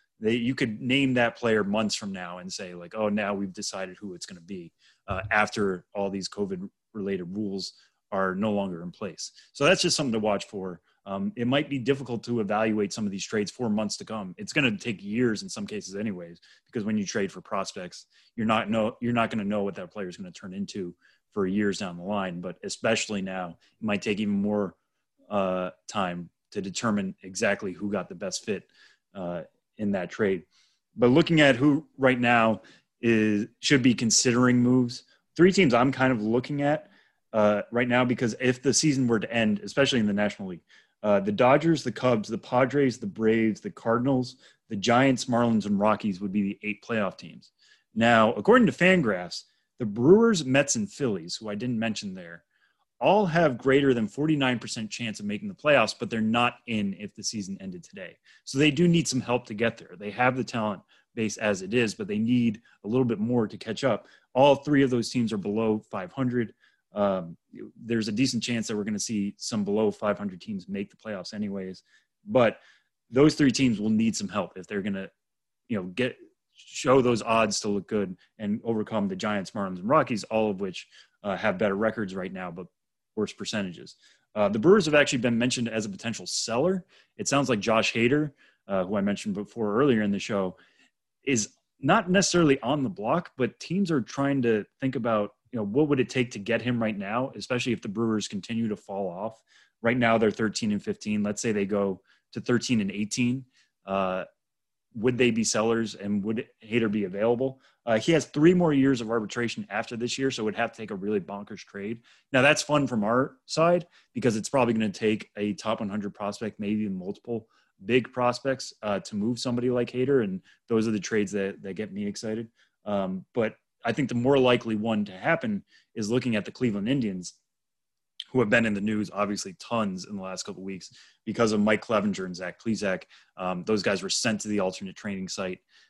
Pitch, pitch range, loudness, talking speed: 115 Hz, 105-135 Hz, -26 LUFS, 210 wpm